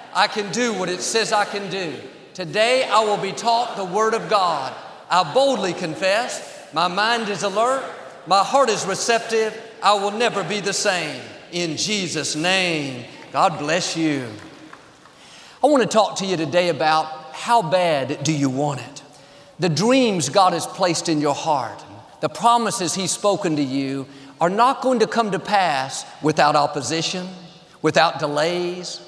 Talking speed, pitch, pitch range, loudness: 165 wpm, 185 Hz, 155-215 Hz, -20 LUFS